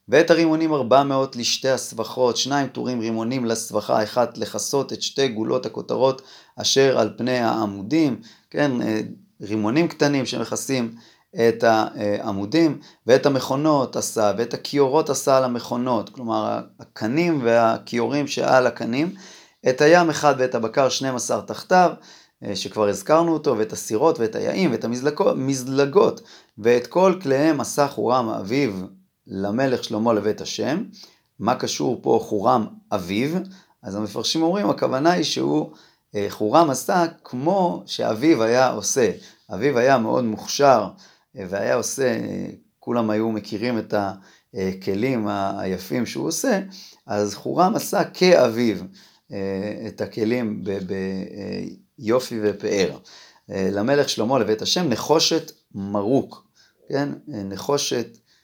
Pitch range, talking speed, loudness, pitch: 105-145 Hz, 120 wpm, -21 LUFS, 120 Hz